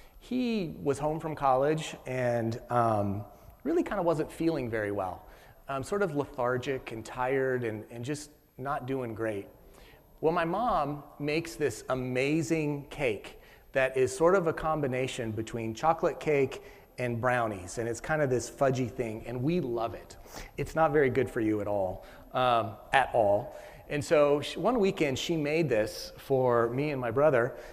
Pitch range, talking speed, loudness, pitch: 115-155 Hz, 170 wpm, -30 LUFS, 130 Hz